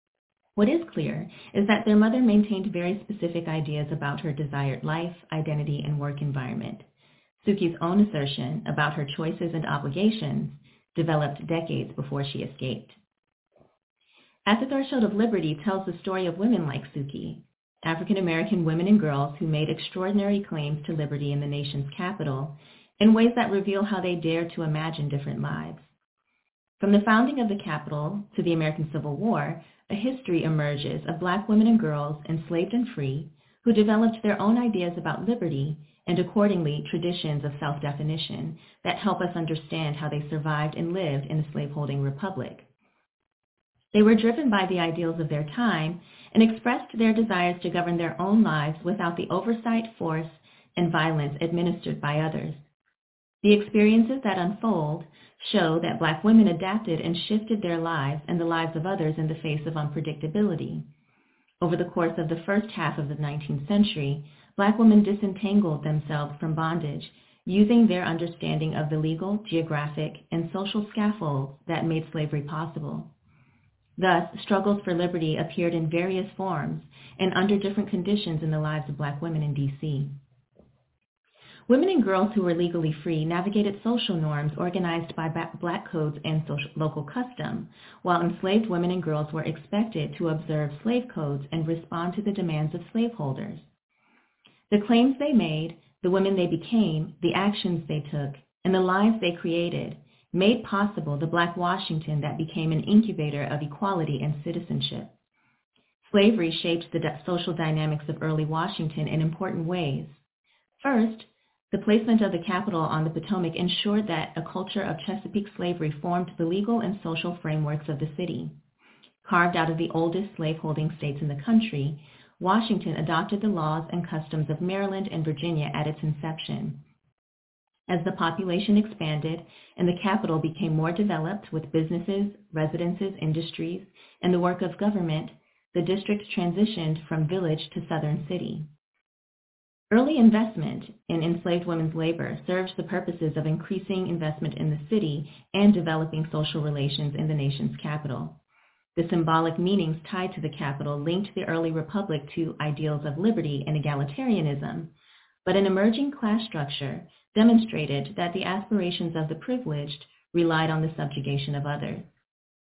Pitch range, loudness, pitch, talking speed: 155-195 Hz, -26 LUFS, 170 Hz, 160 wpm